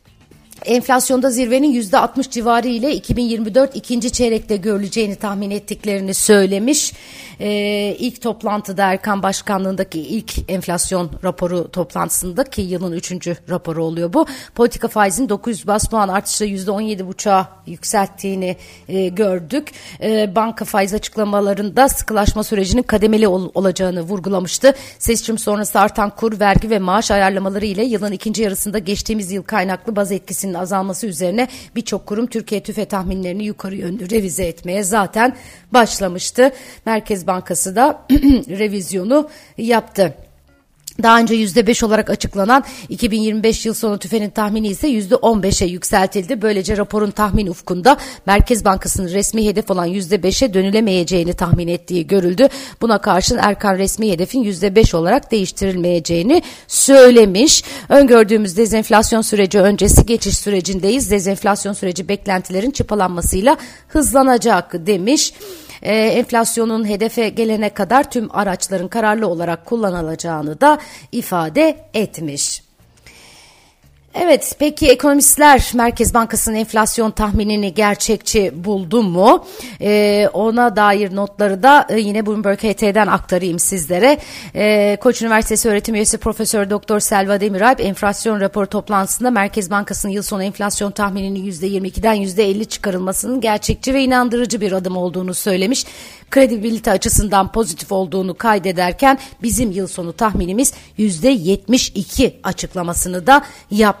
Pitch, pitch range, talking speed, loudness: 210 Hz, 190-230 Hz, 120 wpm, -16 LUFS